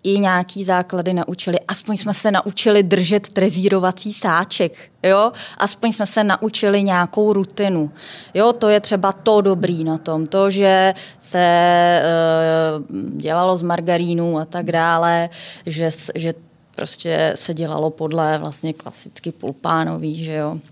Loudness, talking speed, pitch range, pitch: -18 LUFS, 135 wpm, 165-200 Hz, 180 Hz